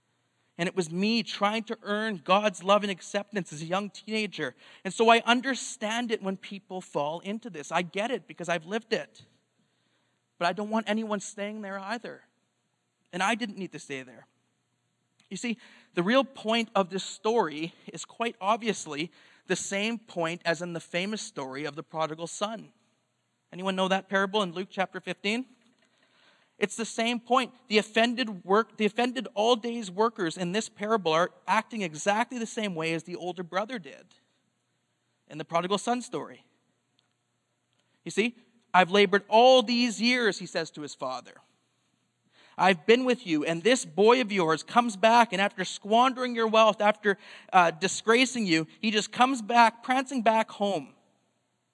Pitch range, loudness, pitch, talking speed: 175-225 Hz, -27 LUFS, 205 Hz, 170 wpm